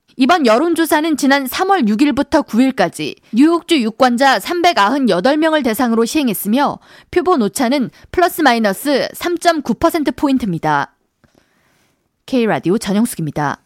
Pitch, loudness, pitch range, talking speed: 270 Hz, -15 LUFS, 220-315 Hz, 270 characters per minute